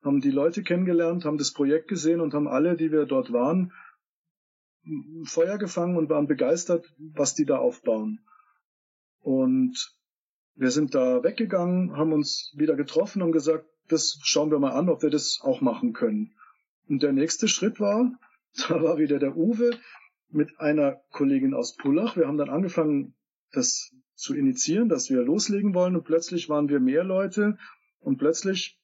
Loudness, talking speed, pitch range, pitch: -25 LUFS, 165 wpm, 155-240 Hz, 175 Hz